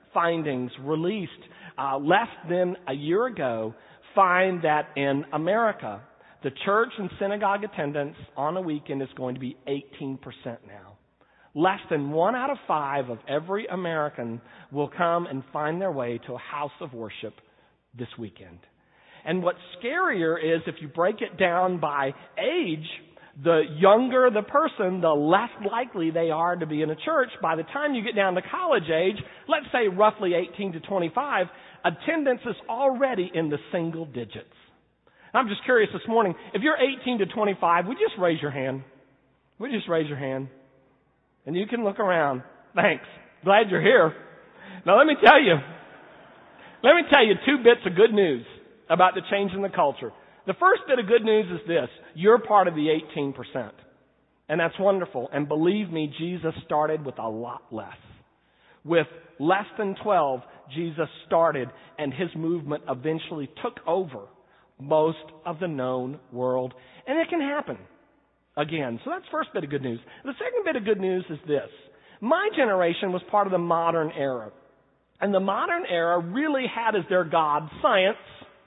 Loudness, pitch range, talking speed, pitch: -25 LUFS, 145-200 Hz, 170 wpm, 170 Hz